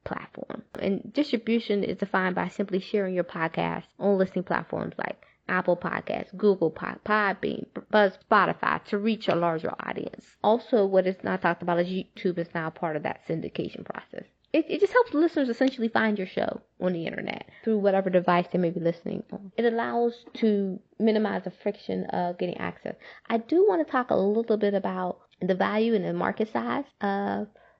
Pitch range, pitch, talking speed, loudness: 180-220 Hz, 200 Hz, 185 wpm, -27 LUFS